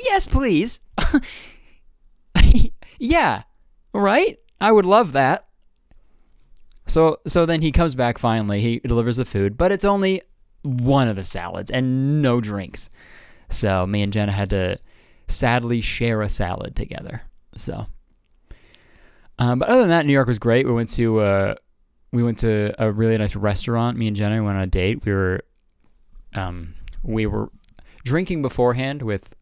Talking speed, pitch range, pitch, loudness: 155 wpm, 100-135 Hz, 115 Hz, -20 LUFS